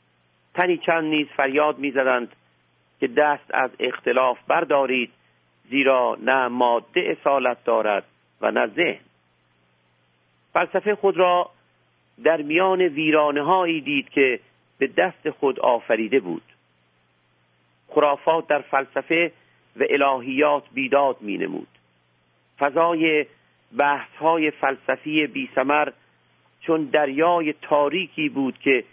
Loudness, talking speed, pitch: -21 LUFS, 105 wpm, 135 Hz